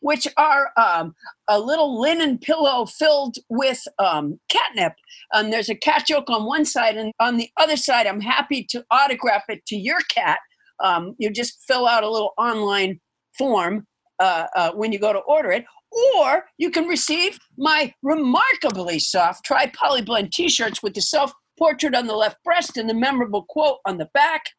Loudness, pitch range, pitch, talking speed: -20 LUFS, 215-300 Hz, 255 Hz, 180 wpm